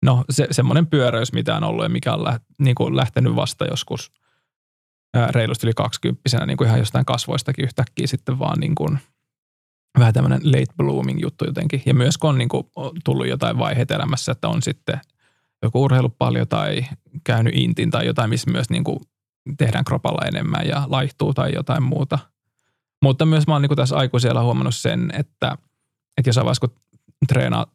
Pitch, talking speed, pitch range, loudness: 130 Hz, 180 wpm, 120-150 Hz, -20 LUFS